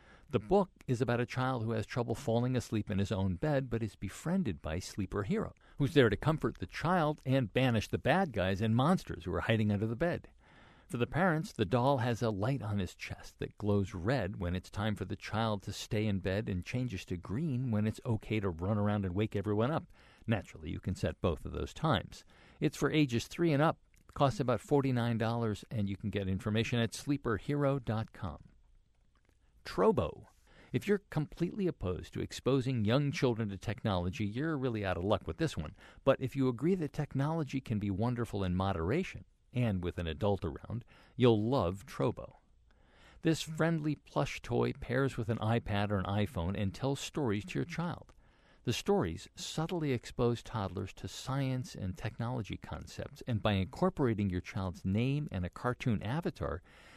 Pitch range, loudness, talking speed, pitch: 100-135 Hz, -34 LUFS, 185 wpm, 115 Hz